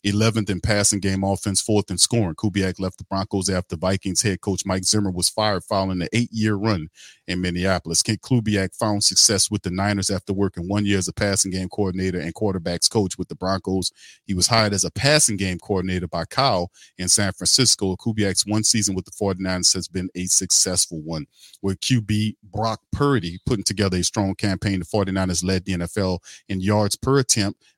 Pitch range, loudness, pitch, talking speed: 95-105 Hz, -21 LUFS, 95 Hz, 195 wpm